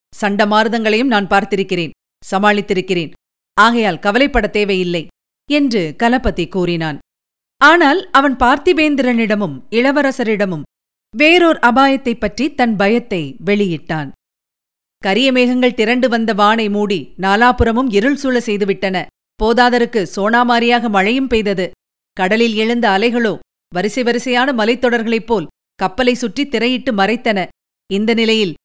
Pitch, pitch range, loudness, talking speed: 220 Hz, 195-245 Hz, -14 LUFS, 95 wpm